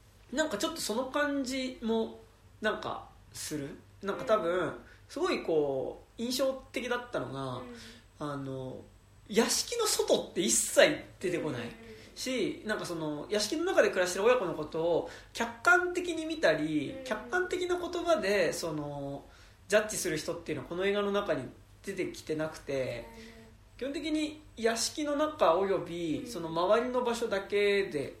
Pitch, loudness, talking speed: 205 Hz, -31 LUFS, 295 characters per minute